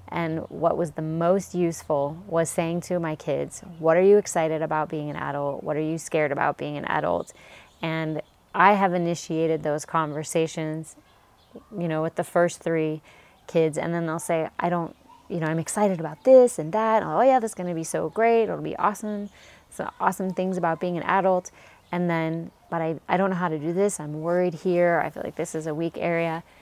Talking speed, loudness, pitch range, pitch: 215 wpm, -25 LUFS, 160-180 Hz, 165 Hz